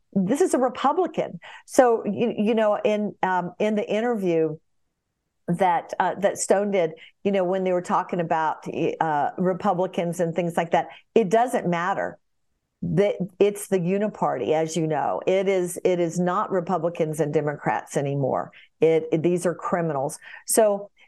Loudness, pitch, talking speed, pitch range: -24 LUFS, 180 Hz, 160 wpm, 165-205 Hz